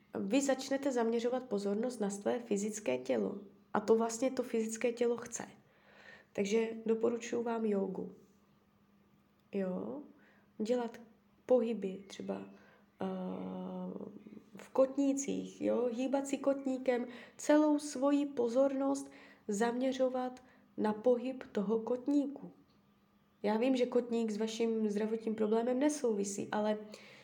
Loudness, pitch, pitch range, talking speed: -35 LUFS, 230 Hz, 210-255 Hz, 105 wpm